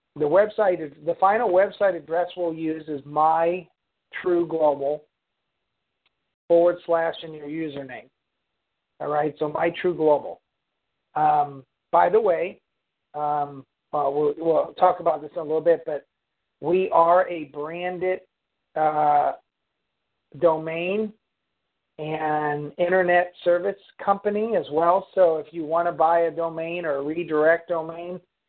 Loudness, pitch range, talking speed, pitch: -23 LUFS, 150-175 Hz, 125 wpm, 165 Hz